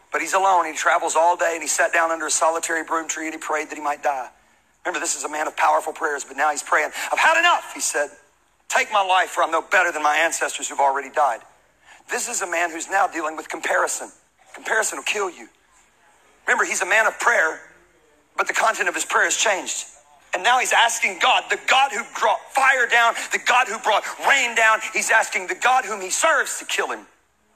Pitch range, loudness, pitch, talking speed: 160-235 Hz, -20 LUFS, 185 Hz, 235 wpm